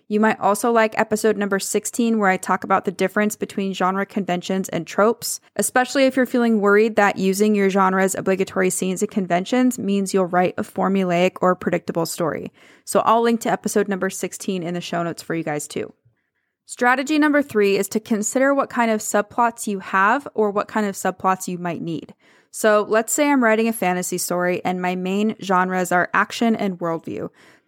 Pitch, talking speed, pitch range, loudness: 200 Hz, 195 wpm, 185-220 Hz, -20 LUFS